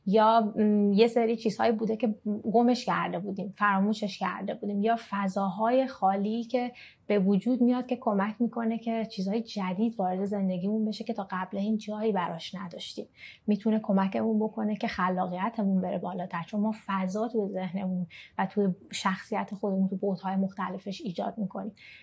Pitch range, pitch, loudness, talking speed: 190-225 Hz, 205 Hz, -29 LUFS, 155 wpm